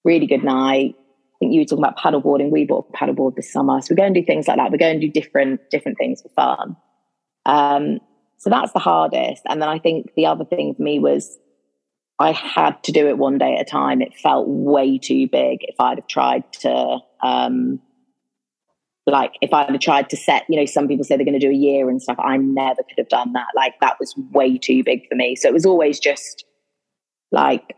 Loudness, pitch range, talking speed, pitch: -18 LUFS, 120-155 Hz, 235 wpm, 140 Hz